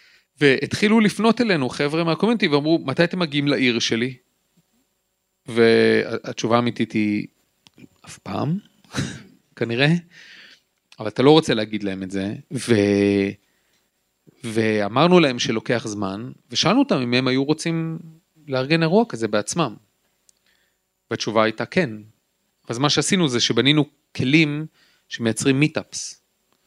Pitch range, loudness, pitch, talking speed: 110-160 Hz, -20 LUFS, 130 Hz, 115 wpm